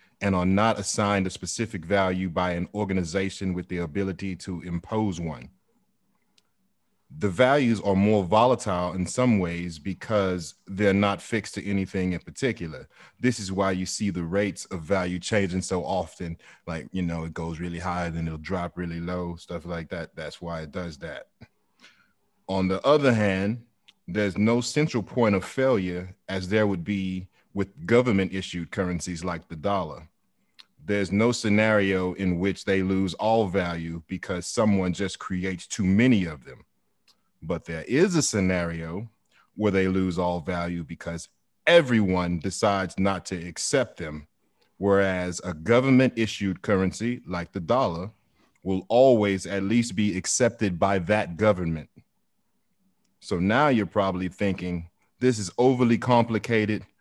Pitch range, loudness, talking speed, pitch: 90-105 Hz, -25 LUFS, 155 wpm, 95 Hz